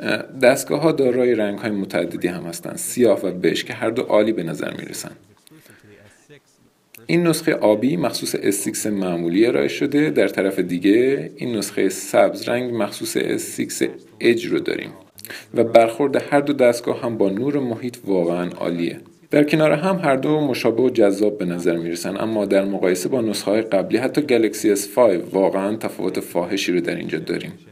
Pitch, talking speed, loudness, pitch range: 120 Hz, 175 wpm, -20 LUFS, 95-150 Hz